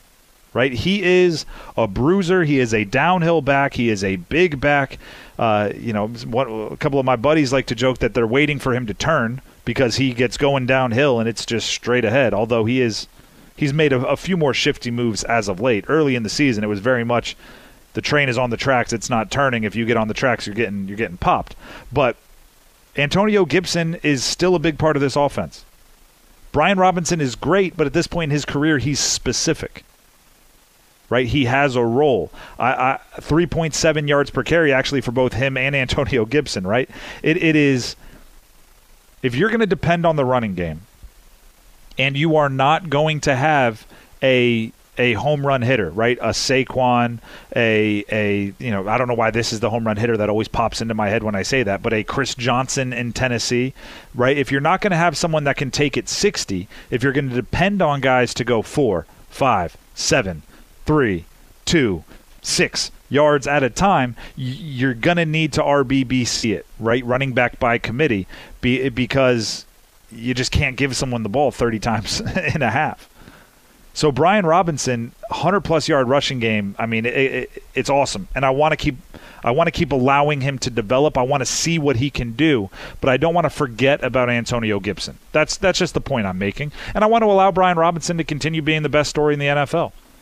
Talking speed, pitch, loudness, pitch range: 205 wpm, 130 Hz, -19 LUFS, 115-150 Hz